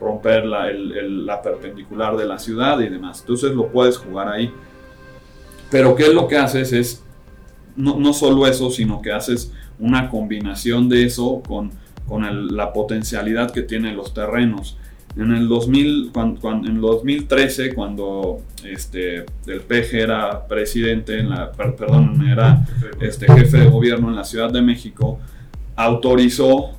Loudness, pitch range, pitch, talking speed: -17 LUFS, 105-130 Hz, 120 Hz, 160 wpm